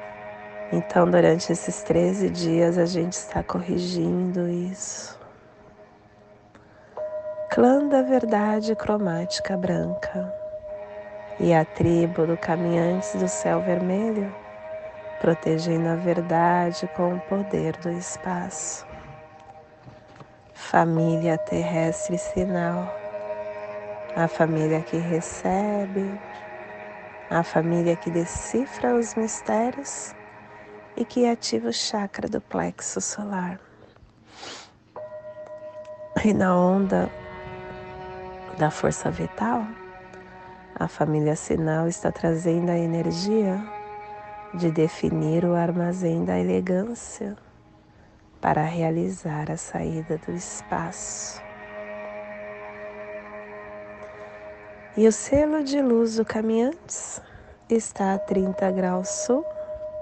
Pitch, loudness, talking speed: 170 Hz, -25 LUFS, 90 wpm